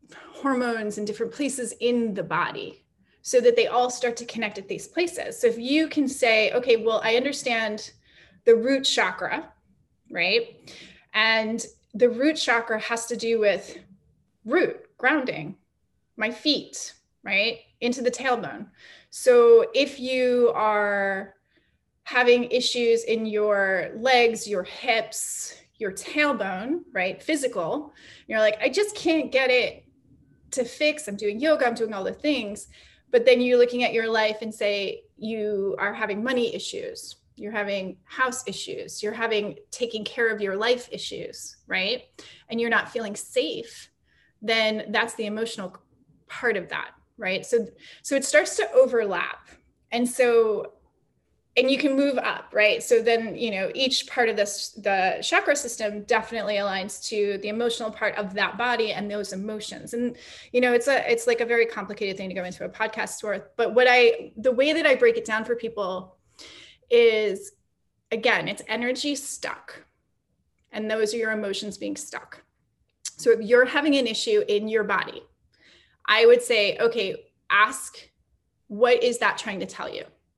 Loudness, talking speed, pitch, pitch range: -24 LUFS, 160 wpm, 235 Hz, 215-295 Hz